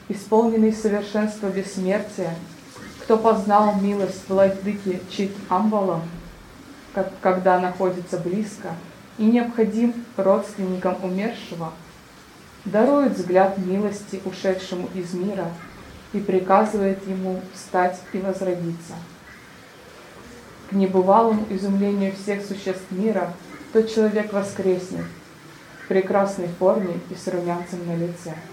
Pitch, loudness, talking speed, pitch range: 195 Hz, -22 LUFS, 95 wpm, 185-205 Hz